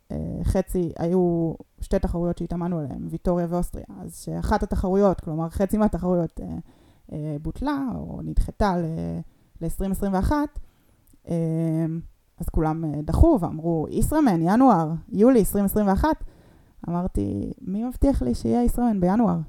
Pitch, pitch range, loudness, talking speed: 175 Hz, 165-210 Hz, -24 LUFS, 100 wpm